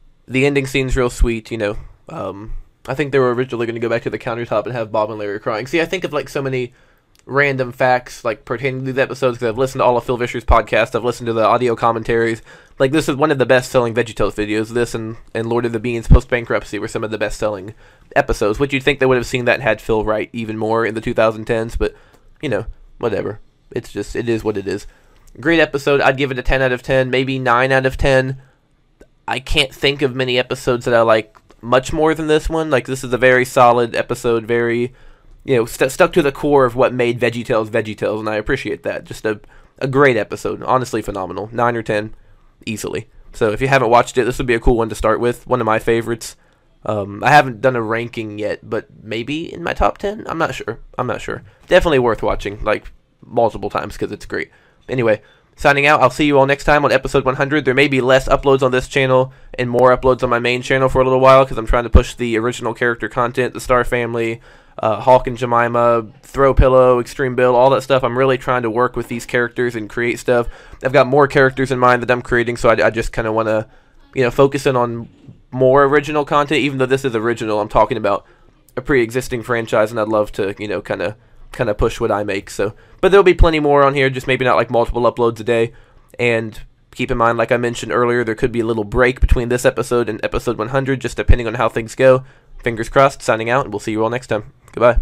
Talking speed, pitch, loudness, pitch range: 245 wpm, 125 Hz, -17 LUFS, 115-130 Hz